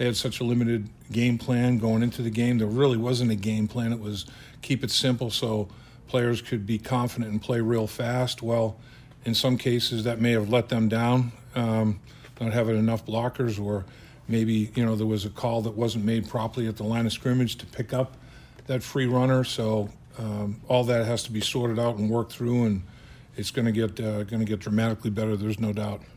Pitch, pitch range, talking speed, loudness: 115 Hz, 110-125 Hz, 220 wpm, -26 LUFS